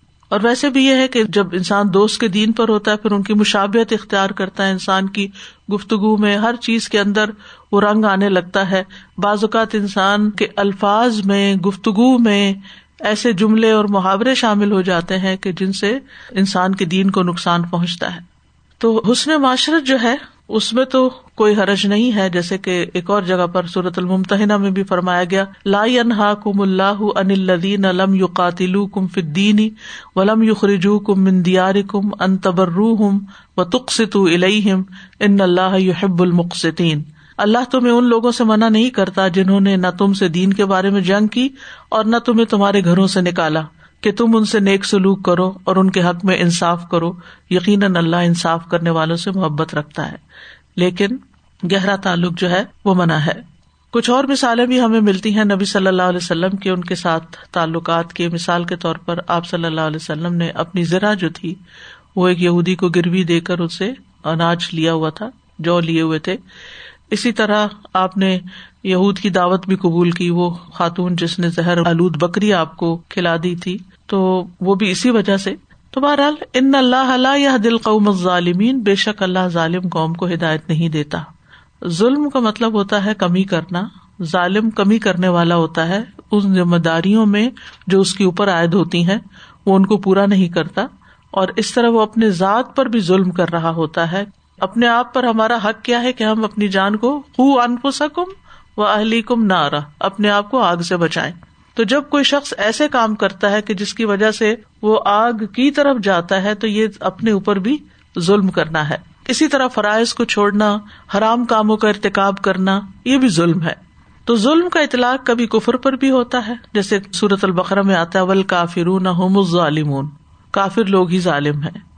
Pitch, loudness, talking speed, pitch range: 195 Hz, -16 LUFS, 195 wpm, 180-220 Hz